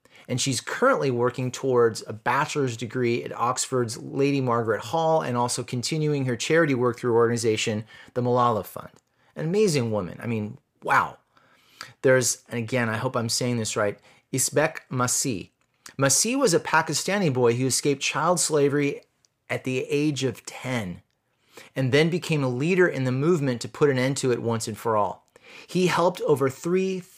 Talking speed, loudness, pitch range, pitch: 170 wpm, -24 LUFS, 120-150 Hz, 130 Hz